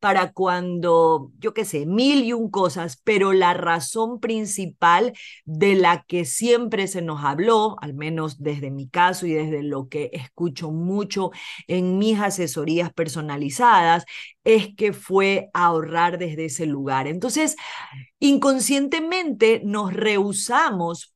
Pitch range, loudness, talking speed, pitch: 160-215 Hz, -21 LUFS, 130 wpm, 180 Hz